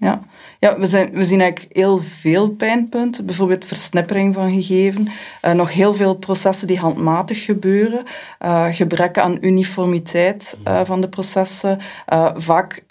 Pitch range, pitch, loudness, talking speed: 175-200 Hz, 190 Hz, -17 LUFS, 150 wpm